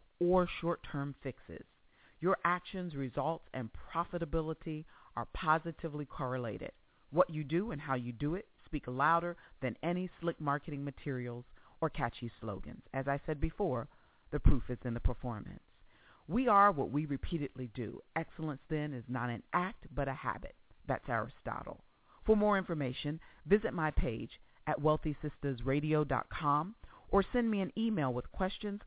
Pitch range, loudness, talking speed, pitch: 130-175 Hz, -36 LUFS, 150 wpm, 150 Hz